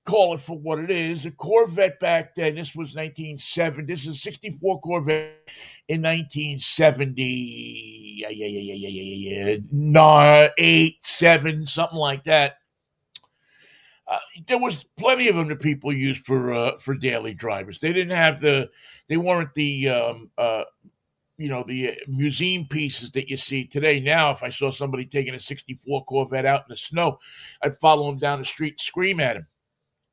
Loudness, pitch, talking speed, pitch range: -21 LUFS, 150 Hz, 175 wpm, 135-165 Hz